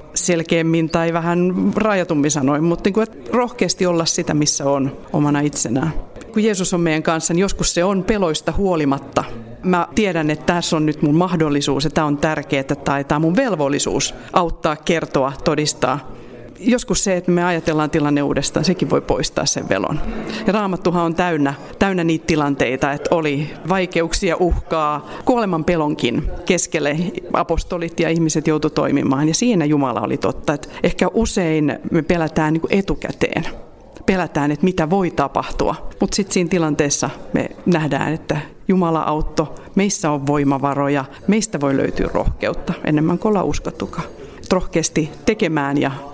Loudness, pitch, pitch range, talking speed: -18 LUFS, 165 Hz, 145-180 Hz, 155 wpm